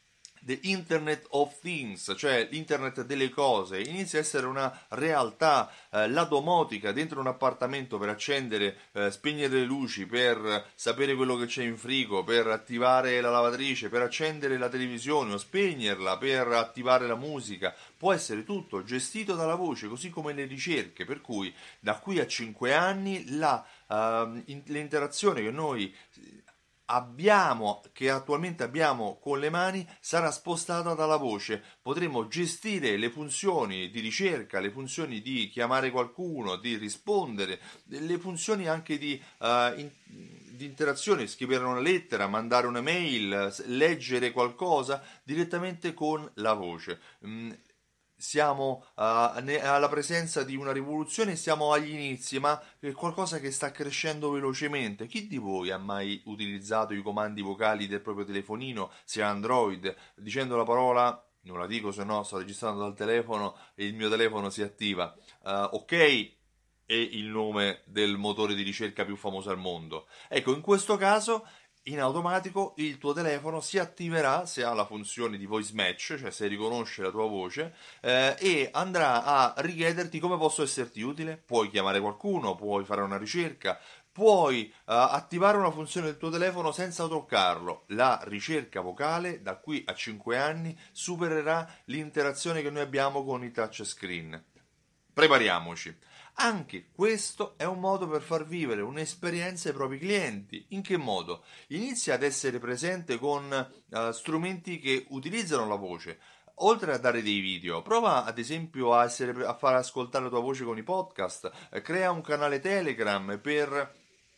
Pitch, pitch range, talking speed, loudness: 135 Hz, 110-160 Hz, 150 wpm, -30 LUFS